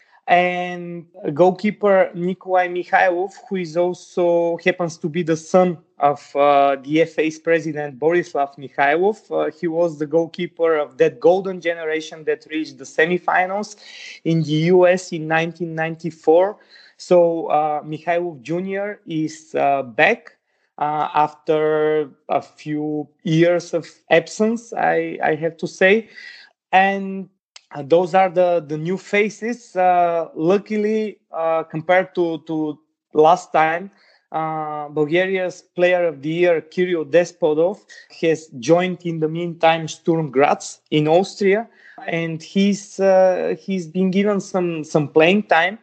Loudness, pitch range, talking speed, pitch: -19 LUFS, 155-185 Hz, 130 wpm, 170 Hz